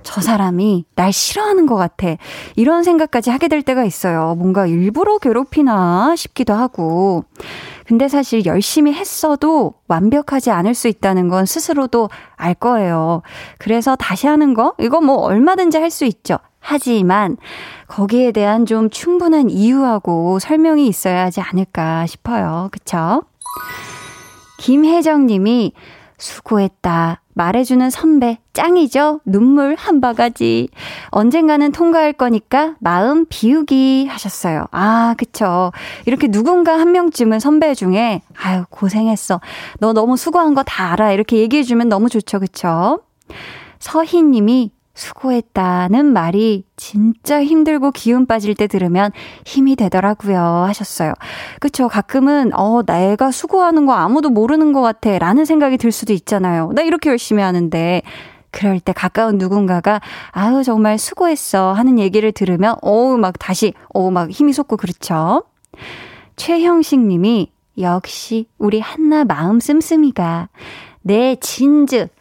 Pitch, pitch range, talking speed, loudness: 225 Hz, 190-280 Hz, 290 characters per minute, -14 LUFS